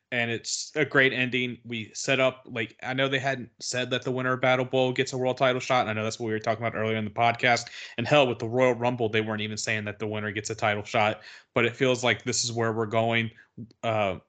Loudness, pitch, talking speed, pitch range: -26 LUFS, 120 Hz, 275 wpm, 110-130 Hz